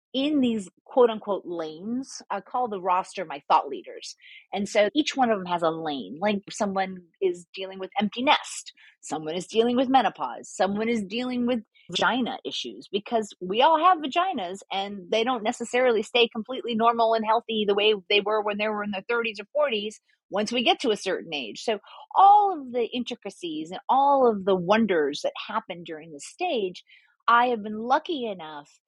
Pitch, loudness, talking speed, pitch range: 225 Hz, -25 LUFS, 190 wpm, 200-260 Hz